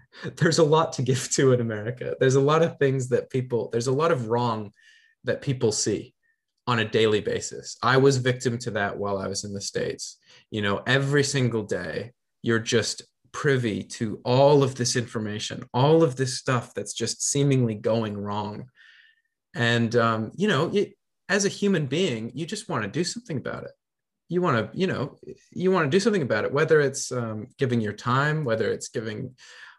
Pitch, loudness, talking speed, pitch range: 130 Hz, -24 LUFS, 195 wpm, 115-165 Hz